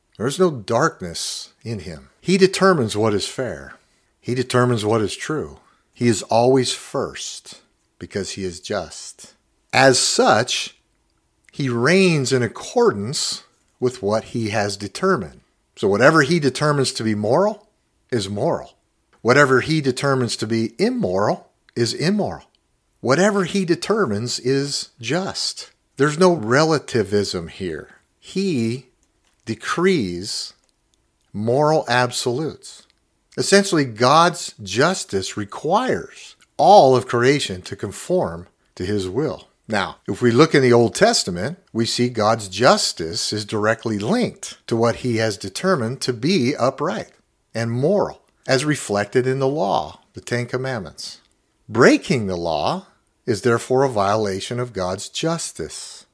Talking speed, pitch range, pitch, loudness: 125 wpm, 110-150 Hz, 125 Hz, -19 LUFS